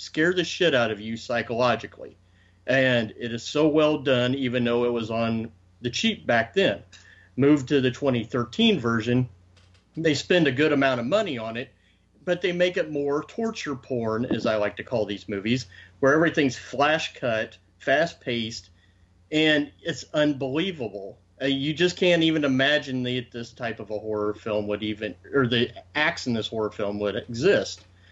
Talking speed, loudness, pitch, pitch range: 175 wpm, -24 LUFS, 120 Hz, 105-145 Hz